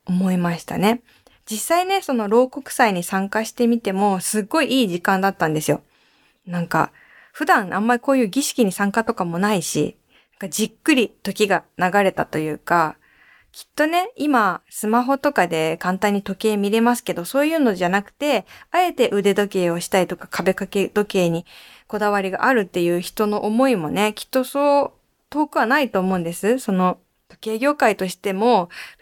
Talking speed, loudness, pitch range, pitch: 350 characters per minute, -20 LUFS, 185-245 Hz, 210 Hz